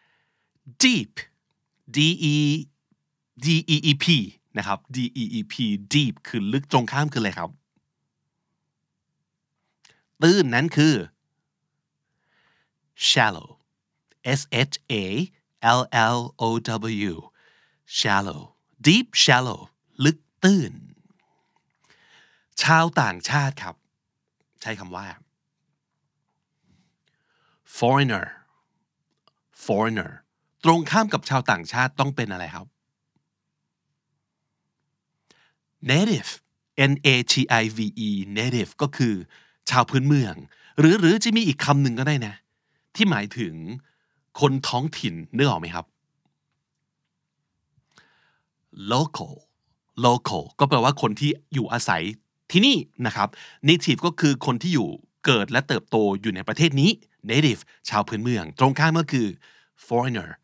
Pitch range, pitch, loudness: 115-155 Hz, 140 Hz, -22 LUFS